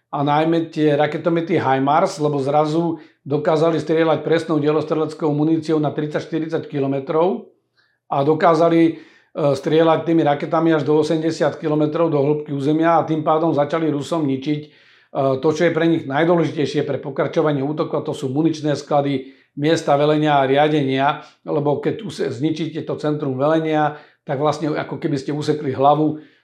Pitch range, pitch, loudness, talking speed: 145-160 Hz, 150 Hz, -19 LUFS, 145 wpm